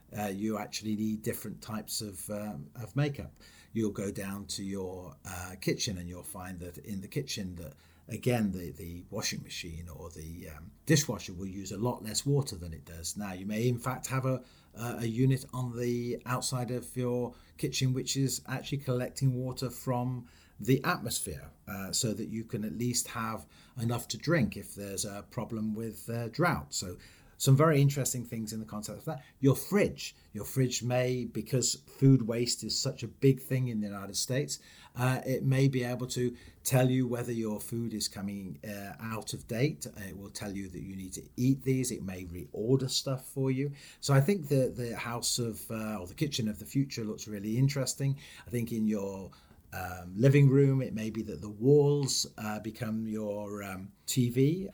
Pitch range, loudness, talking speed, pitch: 100-130 Hz, -32 LUFS, 195 wpm, 115 Hz